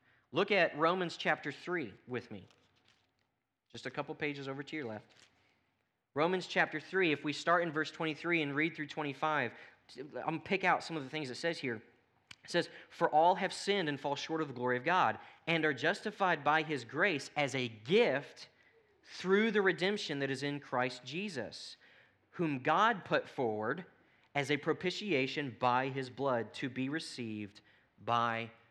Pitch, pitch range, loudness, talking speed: 150 Hz, 125-170 Hz, -34 LUFS, 180 wpm